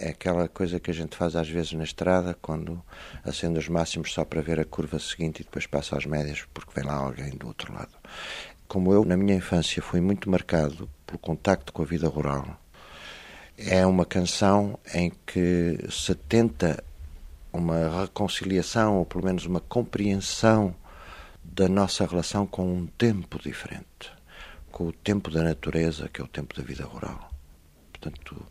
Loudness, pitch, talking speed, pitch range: -27 LUFS, 85 Hz, 170 wpm, 75-95 Hz